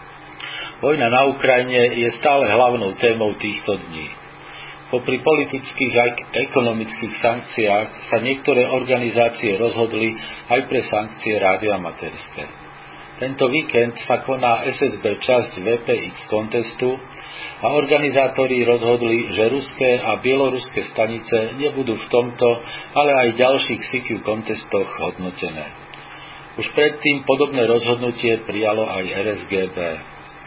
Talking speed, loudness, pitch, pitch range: 105 wpm, -19 LUFS, 120 Hz, 115-130 Hz